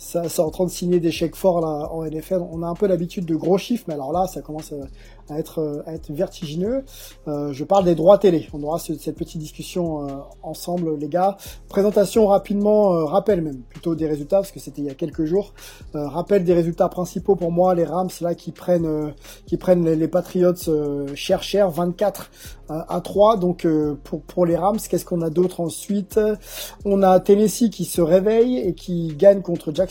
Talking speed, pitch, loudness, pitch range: 215 wpm, 175 Hz, -21 LUFS, 155-190 Hz